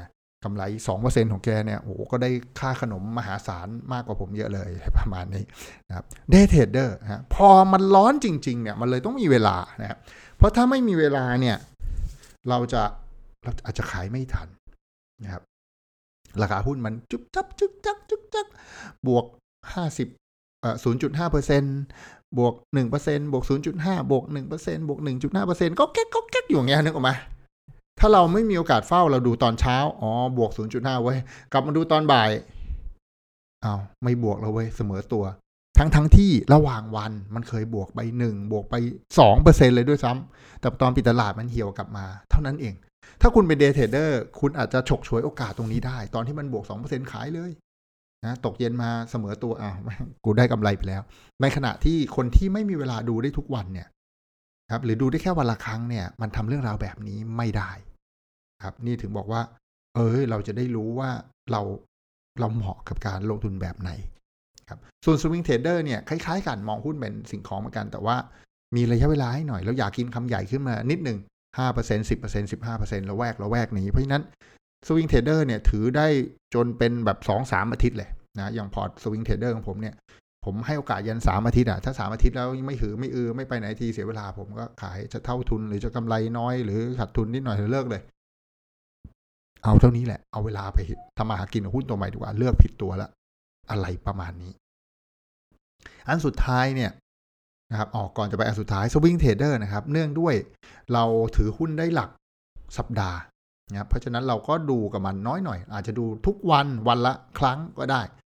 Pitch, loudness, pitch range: 115 Hz, -24 LUFS, 105-135 Hz